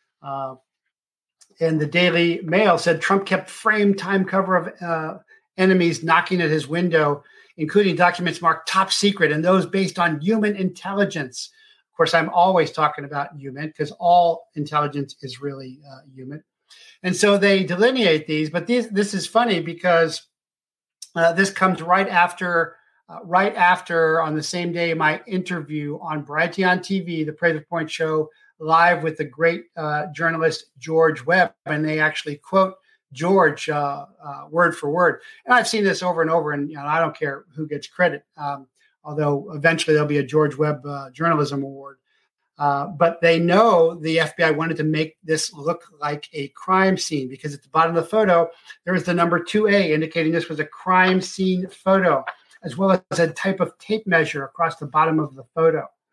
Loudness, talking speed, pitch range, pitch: -20 LUFS, 180 wpm, 155-185 Hz, 165 Hz